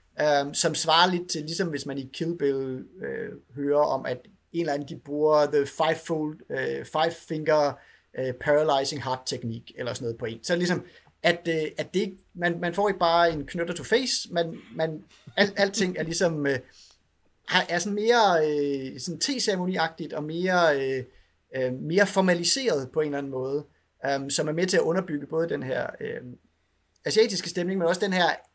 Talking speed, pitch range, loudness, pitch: 185 wpm, 140-175 Hz, -26 LUFS, 160 Hz